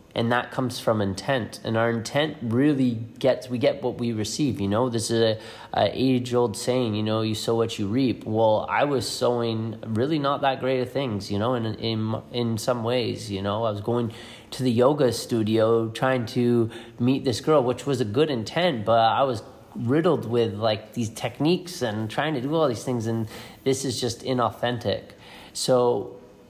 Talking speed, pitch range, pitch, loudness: 200 wpm, 110-130 Hz, 120 Hz, -24 LUFS